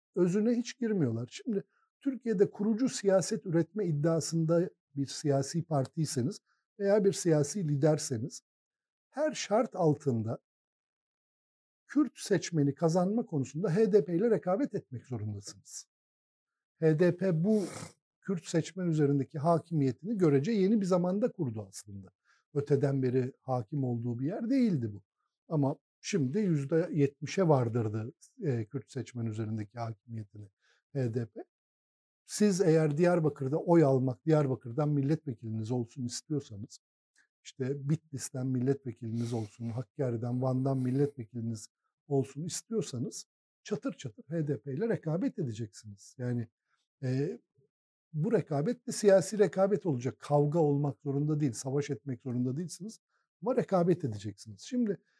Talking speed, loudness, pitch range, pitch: 110 wpm, -31 LUFS, 125-185 Hz, 145 Hz